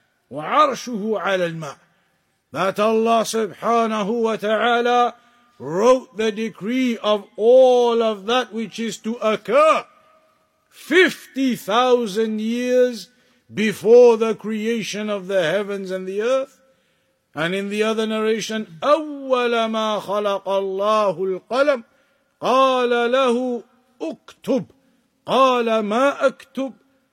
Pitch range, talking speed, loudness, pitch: 210-255 Hz, 100 wpm, -19 LUFS, 230 Hz